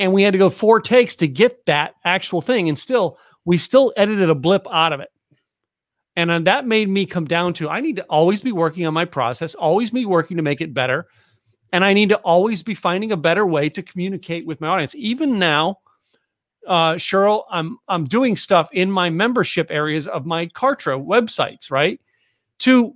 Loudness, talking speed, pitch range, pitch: -18 LUFS, 205 wpm, 165-210 Hz, 180 Hz